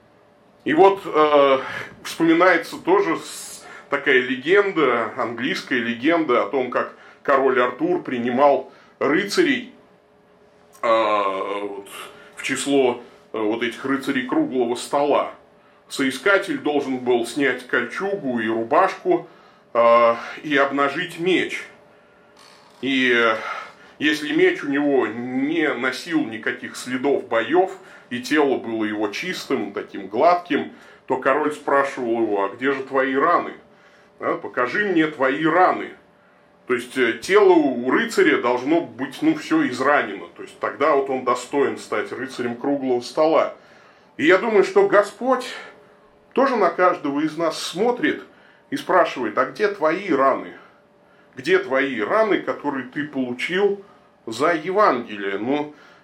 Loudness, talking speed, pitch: -20 LUFS, 125 wpm, 145 Hz